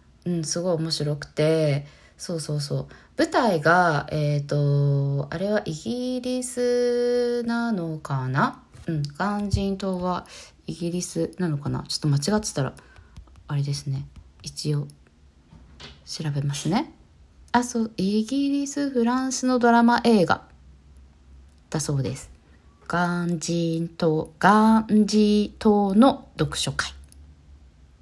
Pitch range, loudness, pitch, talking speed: 140-215 Hz, -24 LUFS, 165 Hz, 215 characters per minute